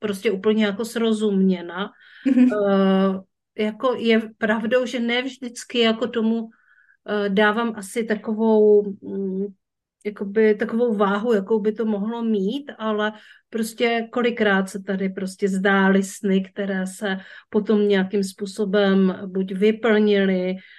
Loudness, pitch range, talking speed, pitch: -21 LUFS, 195-225 Hz, 115 wpm, 210 Hz